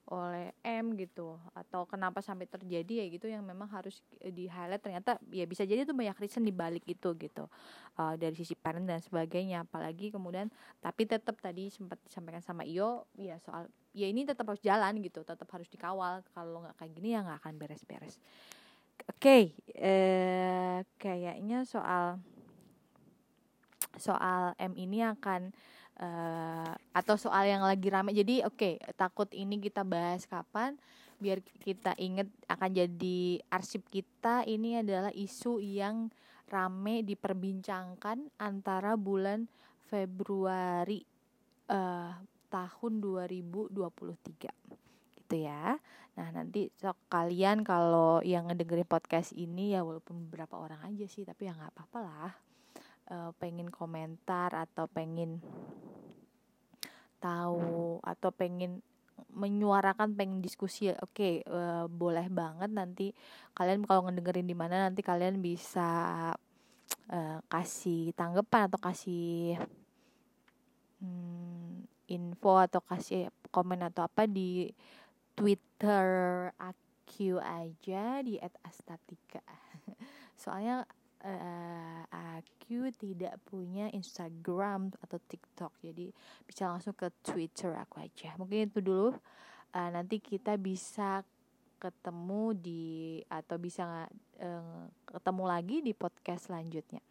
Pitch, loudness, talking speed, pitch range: 185 Hz, -35 LUFS, 125 wpm, 175-205 Hz